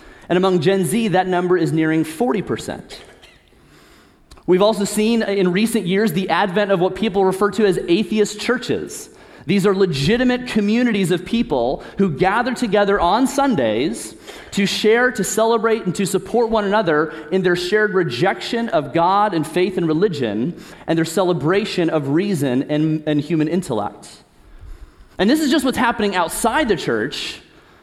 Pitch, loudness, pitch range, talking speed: 195 Hz, -18 LUFS, 175-220 Hz, 155 wpm